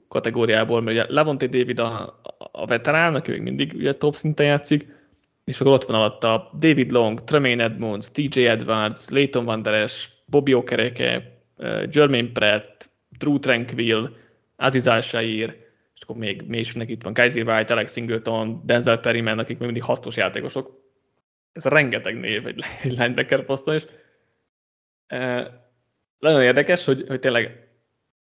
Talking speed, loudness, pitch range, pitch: 140 wpm, -21 LUFS, 110-135 Hz, 120 Hz